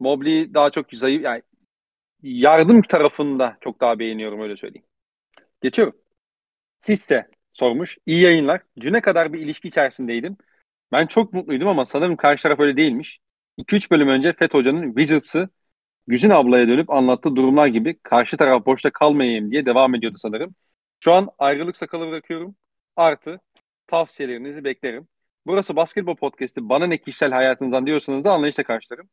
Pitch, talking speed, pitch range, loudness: 150 Hz, 145 wpm, 130-170 Hz, -19 LUFS